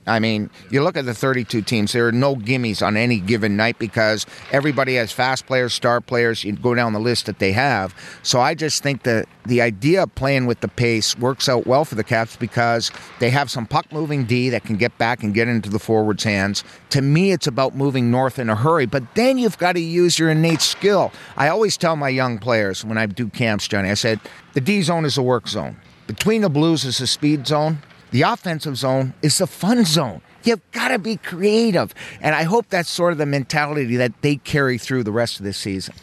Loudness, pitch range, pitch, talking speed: -19 LUFS, 115-155 Hz, 130 Hz, 235 wpm